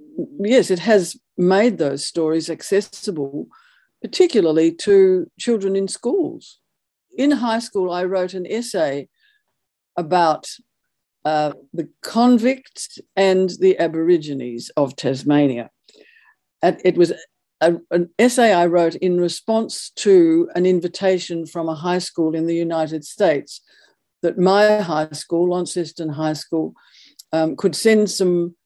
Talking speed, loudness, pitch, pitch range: 125 wpm, -19 LUFS, 180 Hz, 160-225 Hz